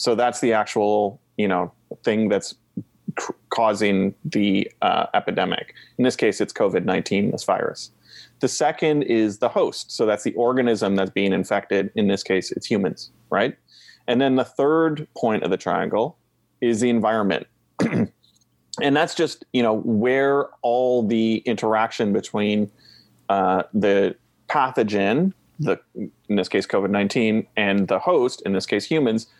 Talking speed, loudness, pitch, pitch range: 150 wpm, -22 LUFS, 110 Hz, 100-120 Hz